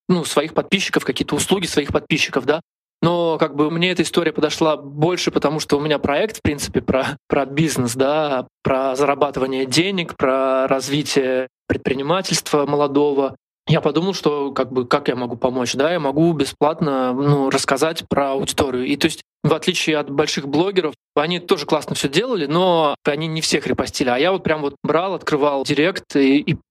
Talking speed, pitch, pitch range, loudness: 180 wpm, 150 Hz, 140-160 Hz, -19 LUFS